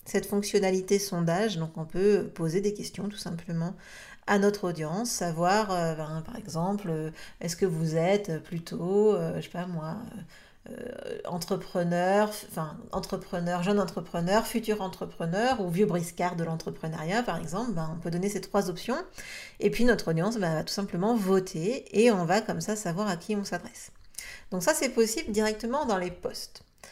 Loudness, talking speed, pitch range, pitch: -29 LUFS, 170 wpm, 170-210 Hz, 190 Hz